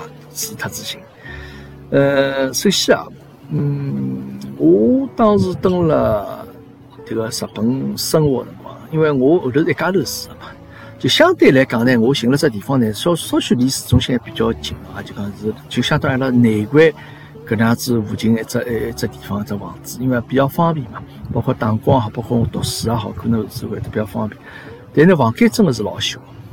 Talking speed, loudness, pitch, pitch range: 275 characters per minute, -17 LUFS, 125 Hz, 110-145 Hz